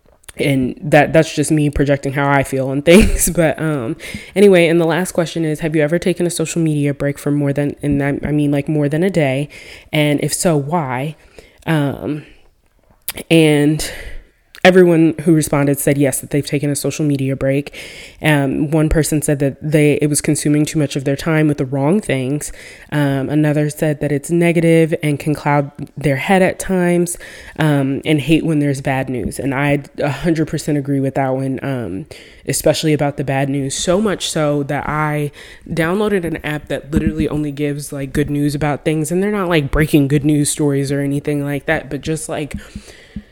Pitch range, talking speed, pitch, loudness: 140-160 Hz, 195 wpm, 150 Hz, -16 LUFS